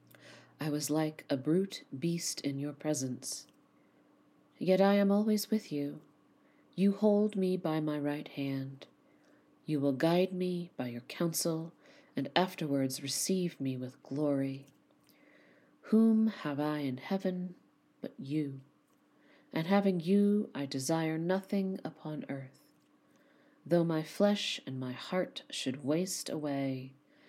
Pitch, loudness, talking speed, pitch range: 155 Hz, -33 LUFS, 130 wpm, 140-190 Hz